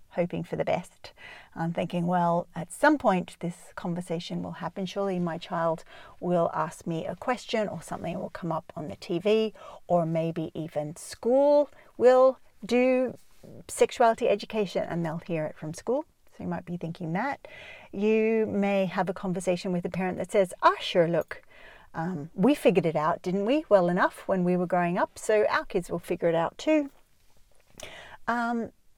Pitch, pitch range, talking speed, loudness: 185 Hz, 170-220 Hz, 180 wpm, -27 LUFS